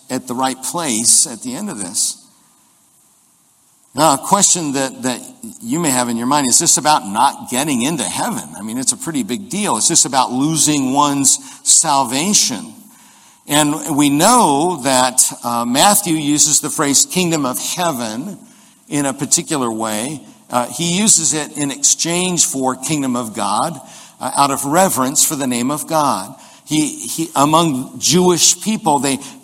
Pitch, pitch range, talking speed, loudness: 155 Hz, 135-210 Hz, 165 wpm, -14 LUFS